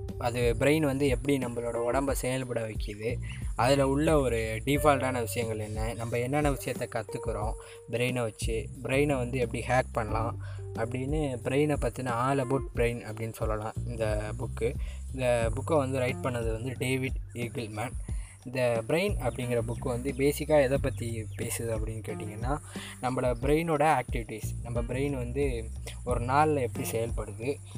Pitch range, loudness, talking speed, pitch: 110-130 Hz, -30 LUFS, 140 wpm, 120 Hz